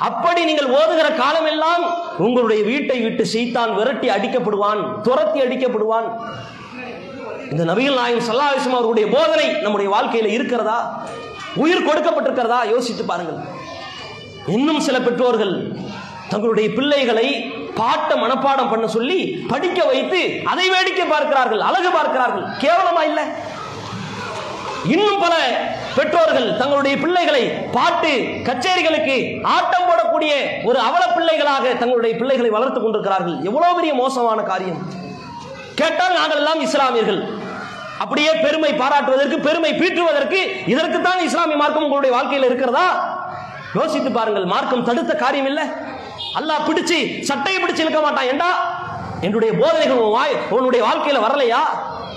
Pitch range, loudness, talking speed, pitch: 235-325 Hz, -17 LUFS, 115 wpm, 280 Hz